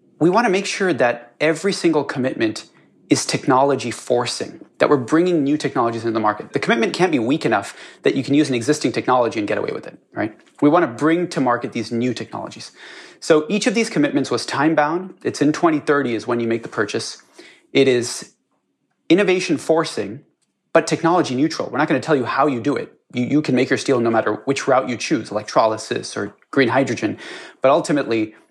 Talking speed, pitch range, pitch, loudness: 210 wpm, 120-165 Hz, 145 Hz, -19 LUFS